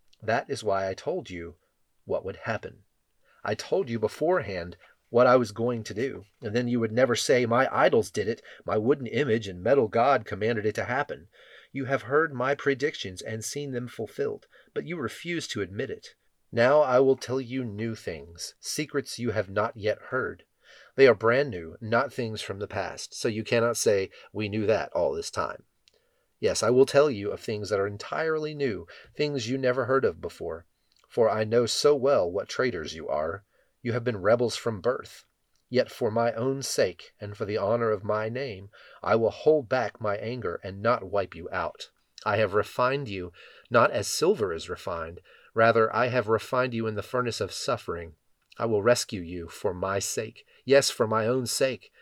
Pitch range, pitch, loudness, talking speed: 110-135 Hz, 120 Hz, -27 LUFS, 200 wpm